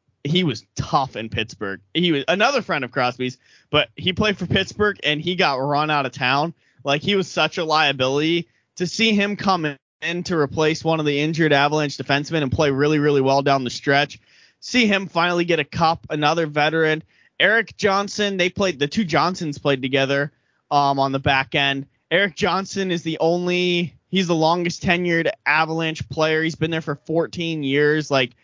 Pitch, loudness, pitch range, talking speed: 155 Hz, -20 LUFS, 140-175 Hz, 190 wpm